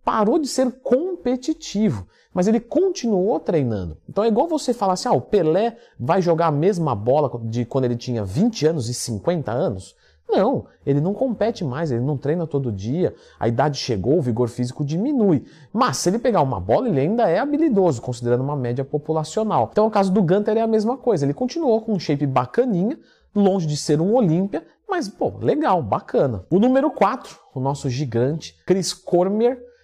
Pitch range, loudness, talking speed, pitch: 135-225 Hz, -21 LUFS, 190 wpm, 175 Hz